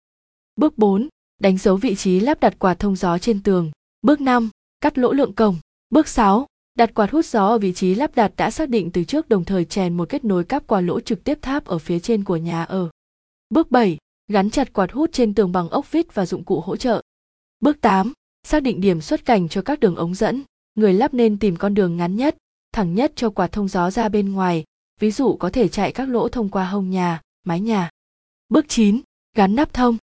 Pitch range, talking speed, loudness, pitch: 185-245 Hz, 230 wpm, -20 LUFS, 215 Hz